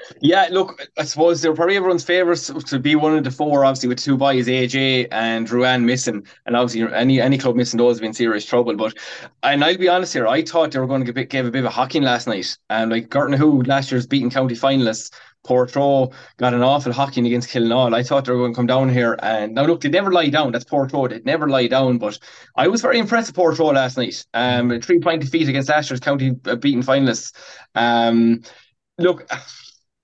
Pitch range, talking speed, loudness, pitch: 120-150 Hz, 230 wpm, -18 LUFS, 130 Hz